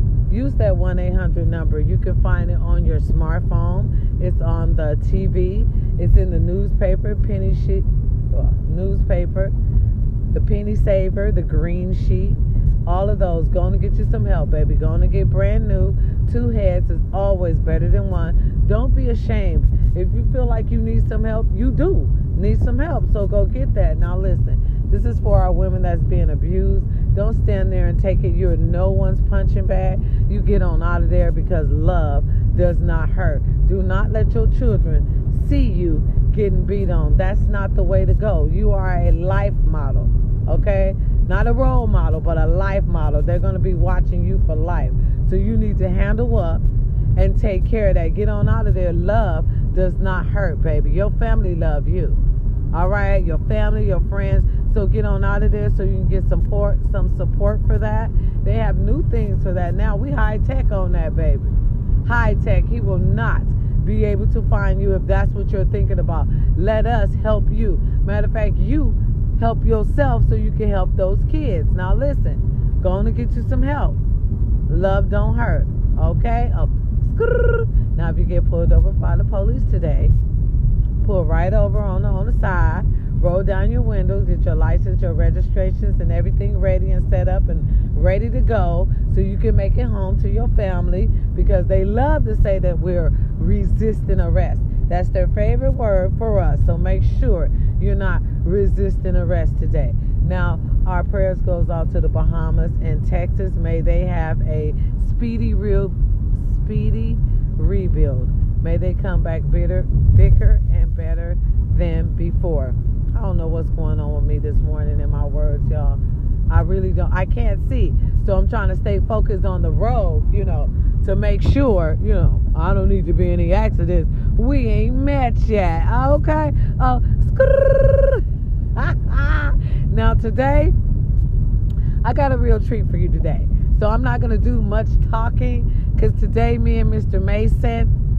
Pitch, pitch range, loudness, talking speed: 105 Hz, 95-115 Hz, -19 LUFS, 180 wpm